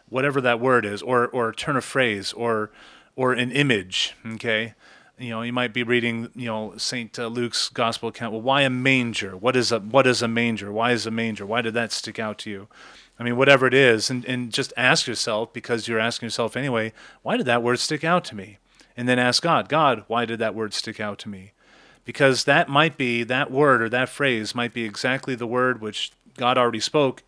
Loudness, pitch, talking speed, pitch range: -22 LUFS, 120 Hz, 225 wpm, 115-130 Hz